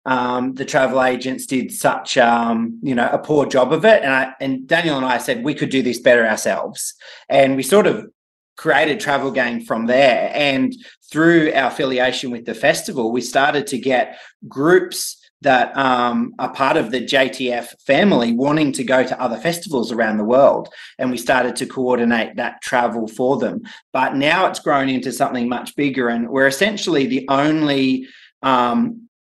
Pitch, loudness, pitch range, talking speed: 130 Hz, -17 LUFS, 125-150 Hz, 180 wpm